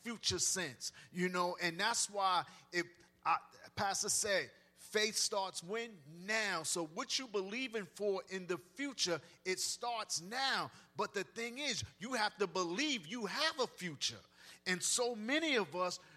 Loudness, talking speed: -37 LUFS, 155 wpm